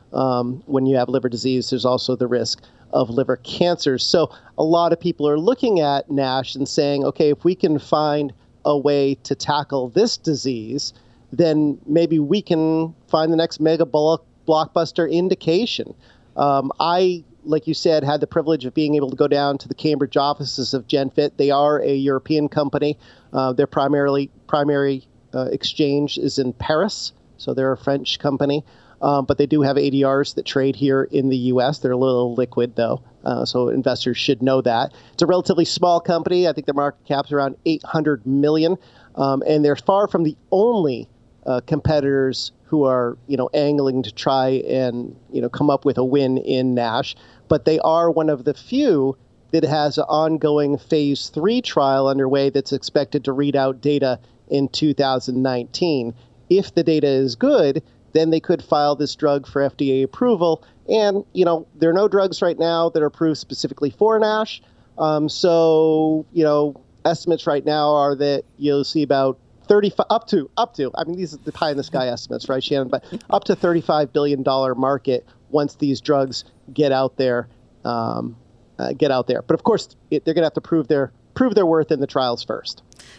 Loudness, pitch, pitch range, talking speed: -20 LUFS, 145 Hz, 130-160 Hz, 190 wpm